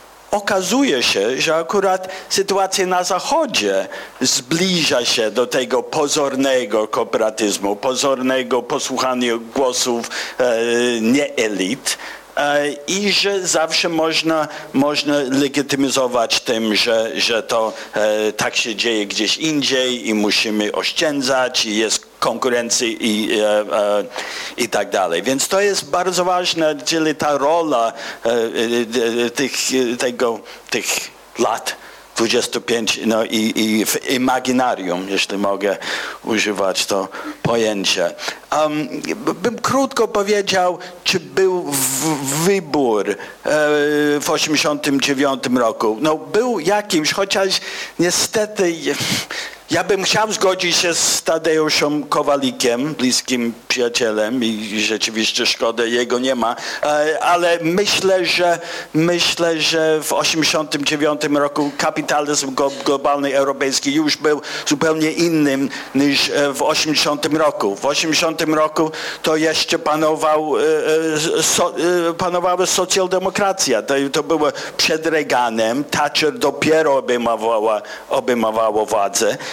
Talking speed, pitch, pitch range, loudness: 105 wpm, 150 Hz, 125-170 Hz, -17 LUFS